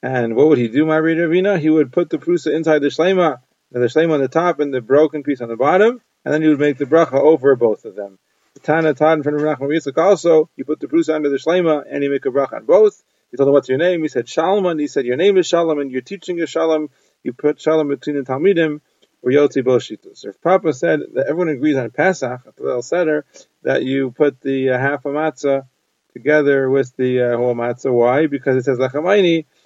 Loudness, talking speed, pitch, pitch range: -17 LUFS, 235 wpm, 150 Hz, 135-165 Hz